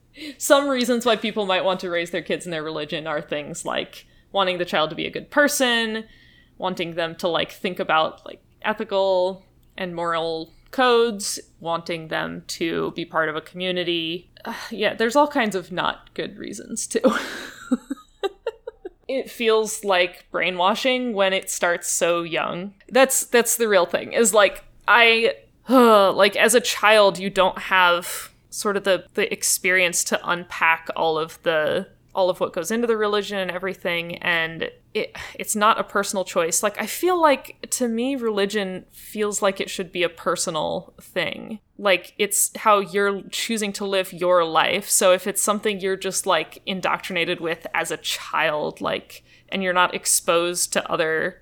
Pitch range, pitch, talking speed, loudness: 175-225 Hz, 195 Hz, 170 wpm, -21 LUFS